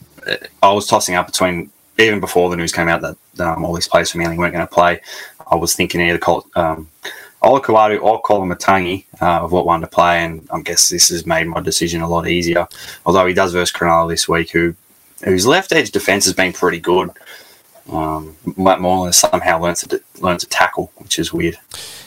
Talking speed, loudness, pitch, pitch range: 220 wpm, -15 LUFS, 90 Hz, 85-95 Hz